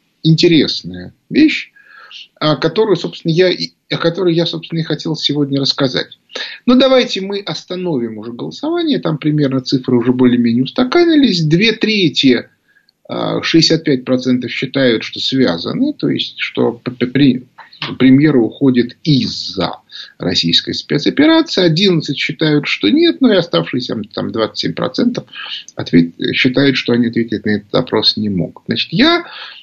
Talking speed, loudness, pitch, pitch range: 120 wpm, -14 LUFS, 150 Hz, 125-195 Hz